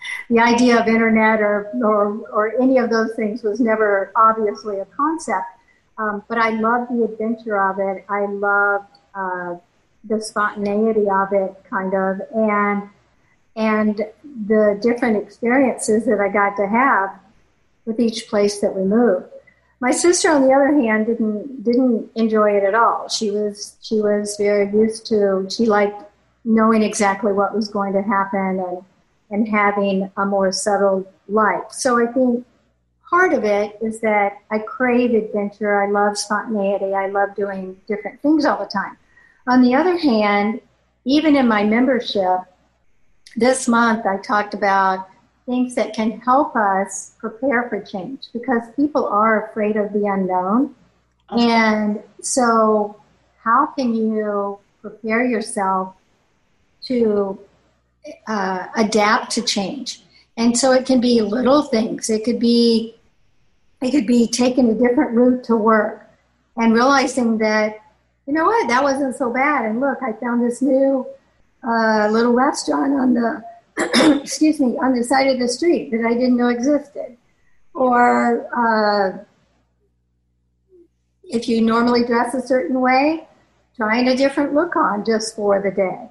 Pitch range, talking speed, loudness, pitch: 205-245 Hz, 150 wpm, -18 LUFS, 220 Hz